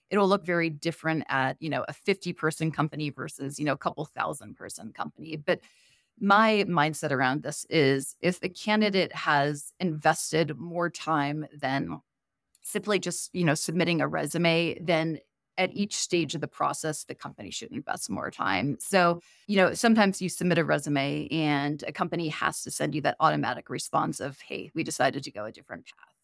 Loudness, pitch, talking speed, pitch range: -27 LUFS, 160 Hz, 185 wpm, 150-180 Hz